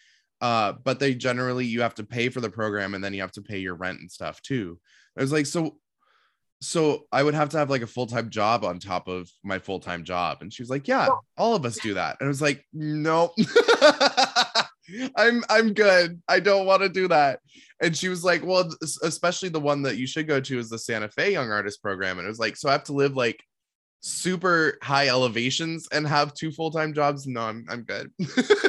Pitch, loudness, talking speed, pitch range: 140 Hz, -24 LUFS, 230 wpm, 115-170 Hz